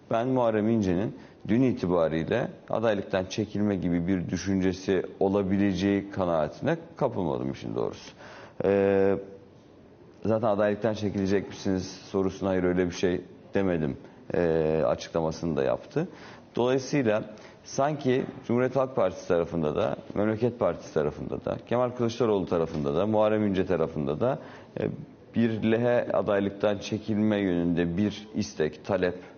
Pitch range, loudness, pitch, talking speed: 90-110 Hz, -27 LUFS, 100 Hz, 120 wpm